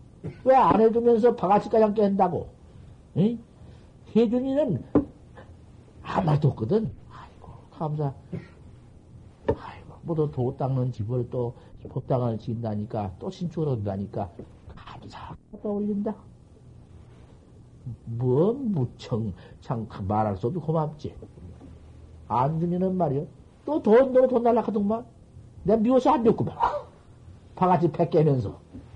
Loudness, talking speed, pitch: -25 LUFS, 230 characters per minute, 140 Hz